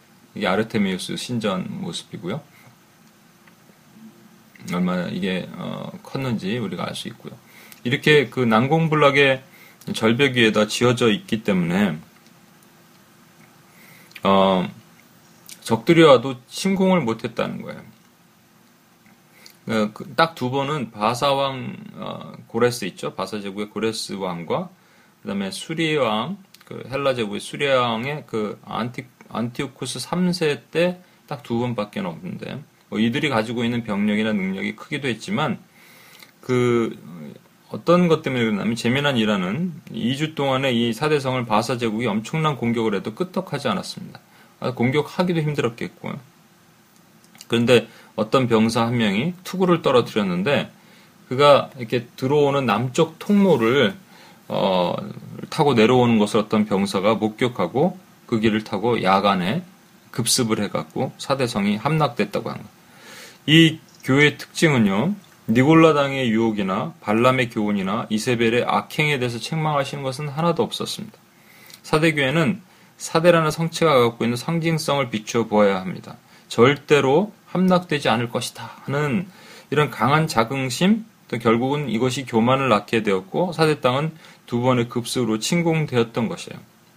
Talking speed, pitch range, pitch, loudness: 285 characters per minute, 115-175 Hz, 140 Hz, -21 LUFS